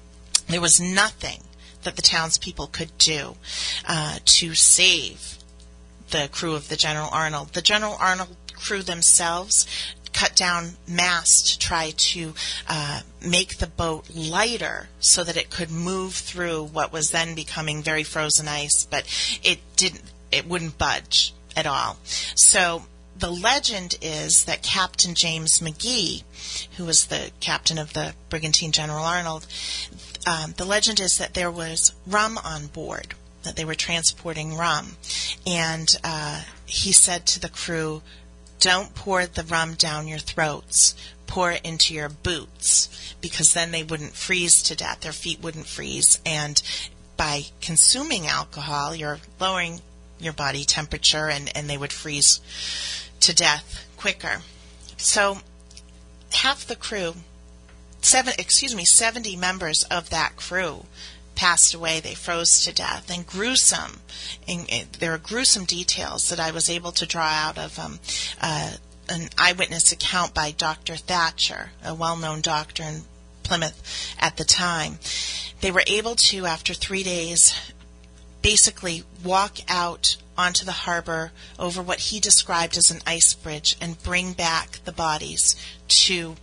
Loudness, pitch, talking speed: -20 LUFS, 160 Hz, 145 wpm